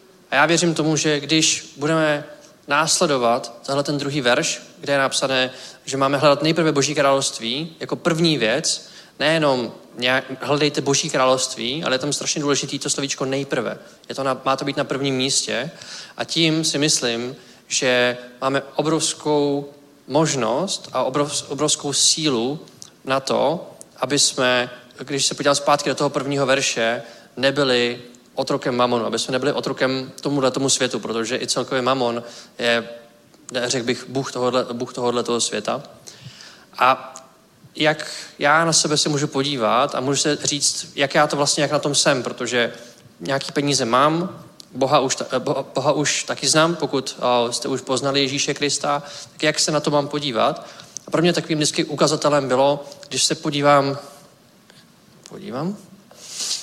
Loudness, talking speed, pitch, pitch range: -20 LUFS, 155 wpm, 140 Hz, 130-150 Hz